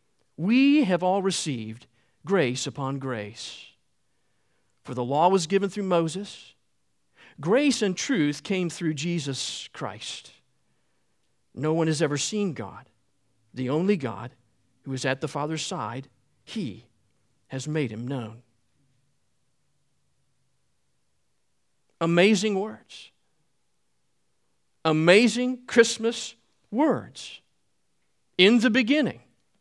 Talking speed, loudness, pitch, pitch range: 100 wpm, -25 LUFS, 145 Hz, 115-190 Hz